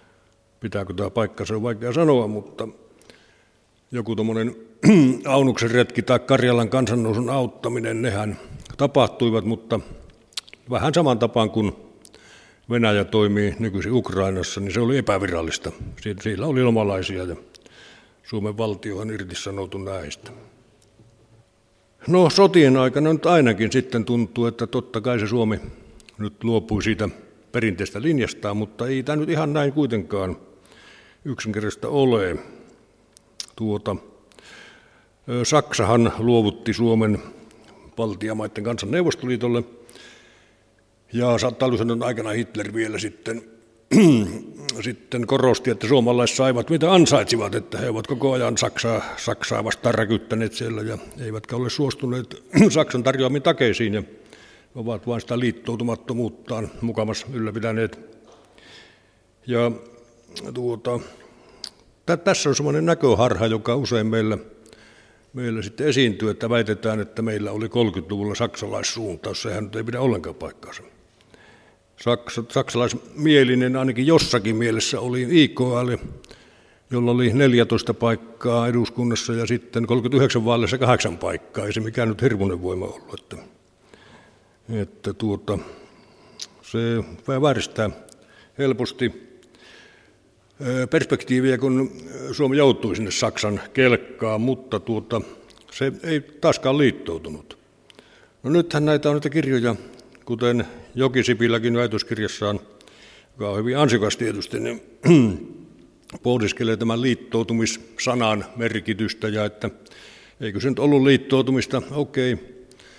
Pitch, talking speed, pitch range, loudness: 115 Hz, 110 wpm, 110-125 Hz, -22 LUFS